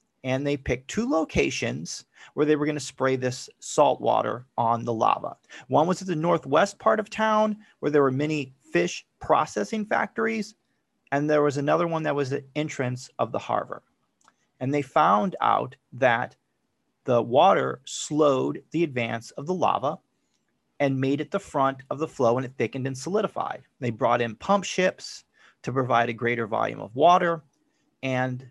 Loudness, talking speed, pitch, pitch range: -25 LUFS, 175 wpm, 145 Hz, 130-170 Hz